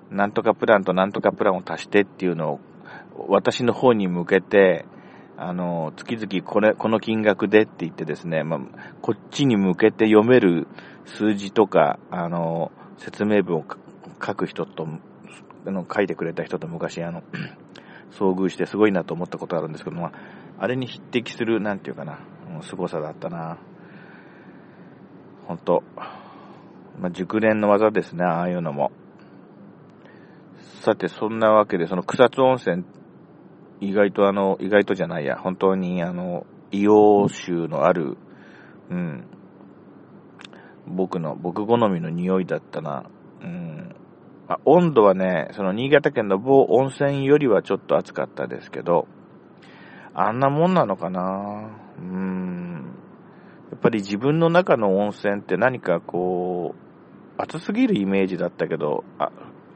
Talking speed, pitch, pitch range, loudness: 275 characters per minute, 100 Hz, 90-110 Hz, -22 LUFS